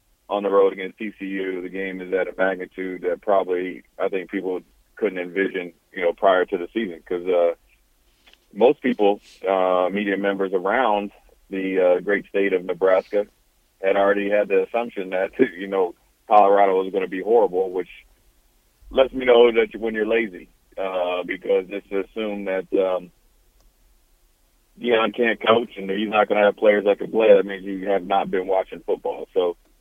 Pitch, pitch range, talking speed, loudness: 100 Hz, 95-115 Hz, 180 wpm, -21 LUFS